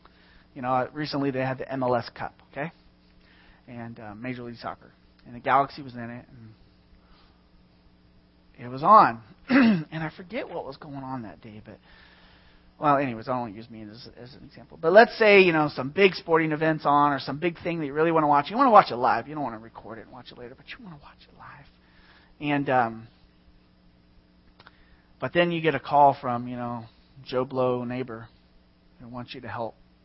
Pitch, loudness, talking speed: 120 Hz, -23 LUFS, 210 wpm